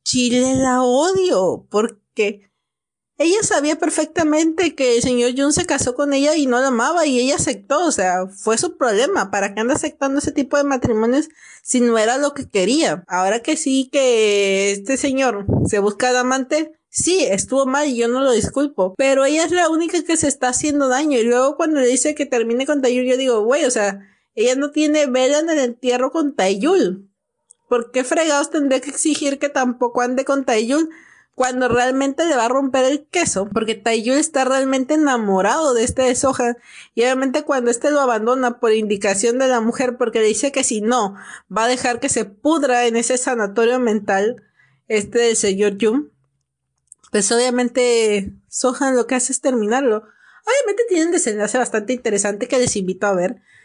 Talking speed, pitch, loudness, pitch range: 190 wpm, 255 Hz, -18 LUFS, 225-285 Hz